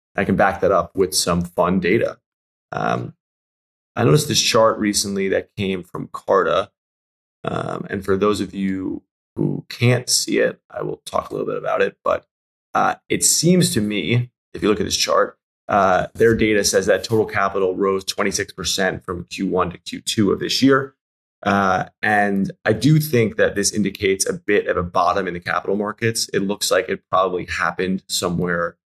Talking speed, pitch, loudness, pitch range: 185 wpm, 100 Hz, -19 LUFS, 95-110 Hz